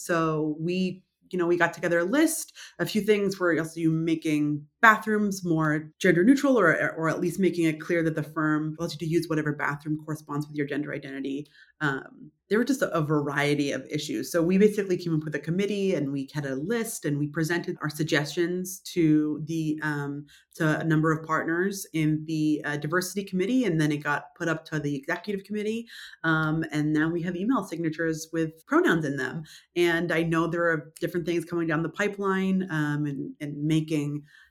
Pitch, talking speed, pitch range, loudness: 160 Hz, 205 wpm, 150-180 Hz, -27 LUFS